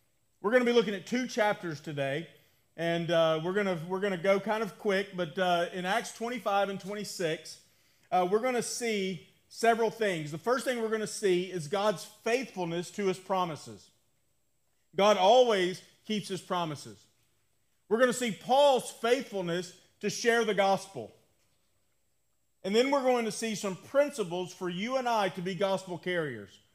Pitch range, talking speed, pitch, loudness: 170-220 Hz, 175 wpm, 190 Hz, -30 LUFS